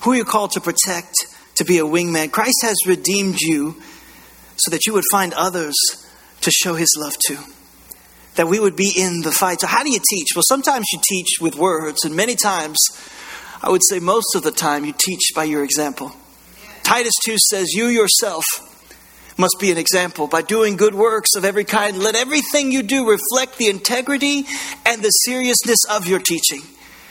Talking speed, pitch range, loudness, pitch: 195 wpm, 170-225 Hz, -16 LUFS, 190 Hz